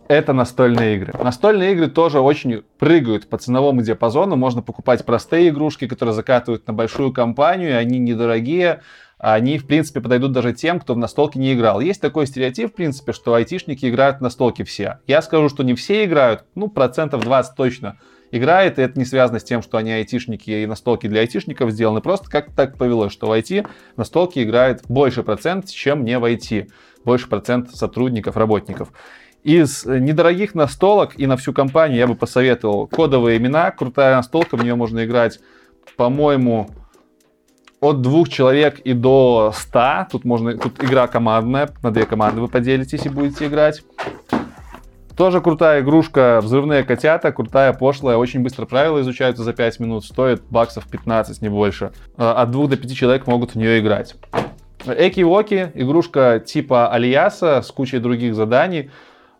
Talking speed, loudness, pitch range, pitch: 165 wpm, -17 LUFS, 115-145 Hz, 125 Hz